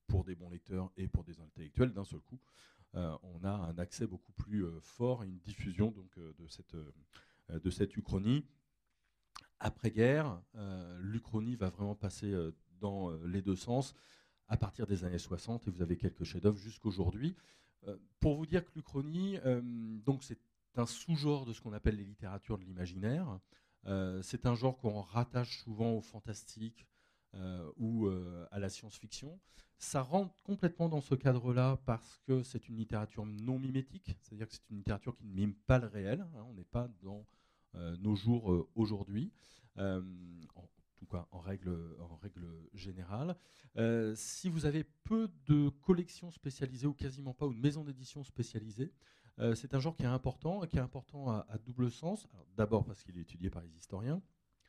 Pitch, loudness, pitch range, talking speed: 110 Hz, -39 LUFS, 95-130 Hz, 190 wpm